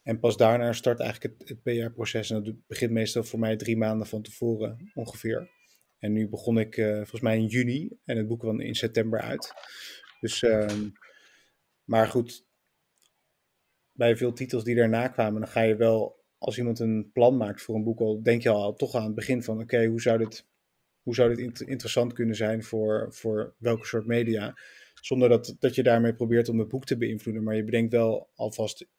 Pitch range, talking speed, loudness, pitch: 110-120 Hz, 195 wpm, -27 LUFS, 115 Hz